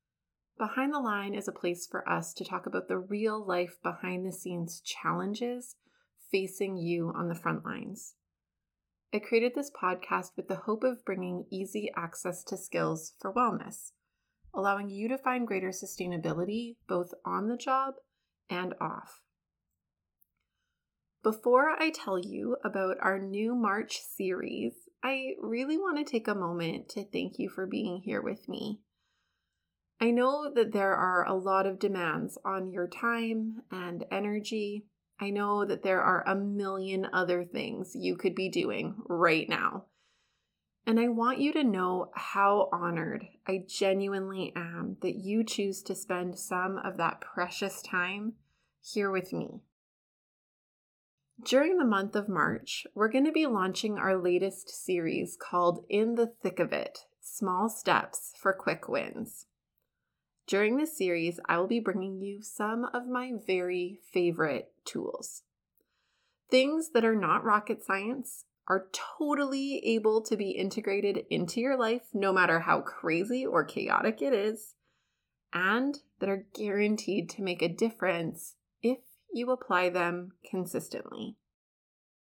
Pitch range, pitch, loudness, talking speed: 185-230 Hz, 200 Hz, -31 LUFS, 145 wpm